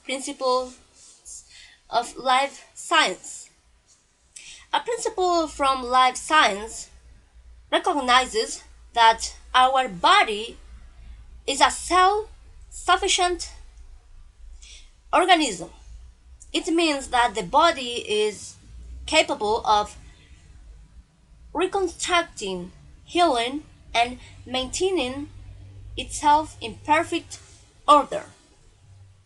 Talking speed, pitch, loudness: 70 wpm, 255 Hz, -22 LUFS